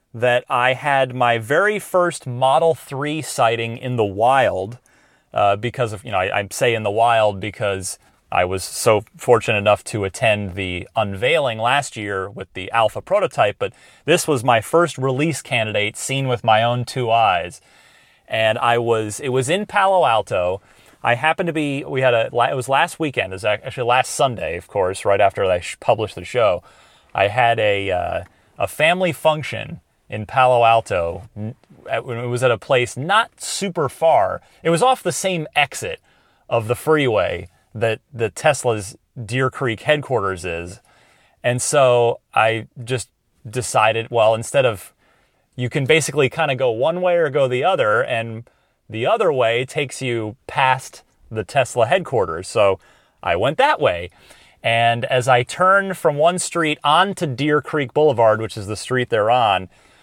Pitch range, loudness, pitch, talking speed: 110-145 Hz, -19 LUFS, 125 Hz, 170 wpm